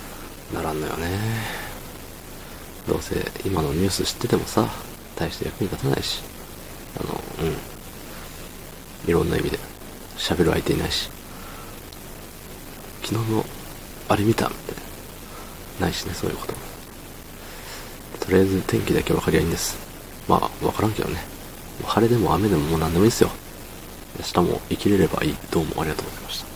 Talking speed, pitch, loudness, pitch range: 315 characters per minute, 95 Hz, -24 LUFS, 85-110 Hz